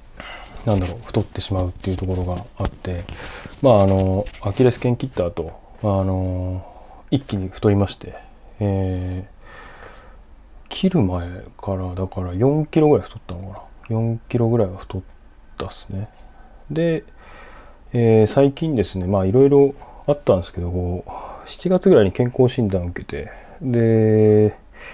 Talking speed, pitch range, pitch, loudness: 280 characters per minute, 90-120 Hz, 100 Hz, -20 LUFS